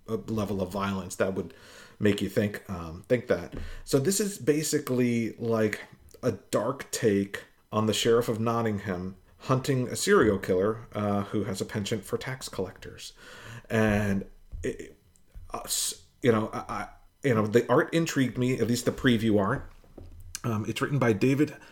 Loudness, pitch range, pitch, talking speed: -28 LUFS, 100-125 Hz, 110 Hz, 165 wpm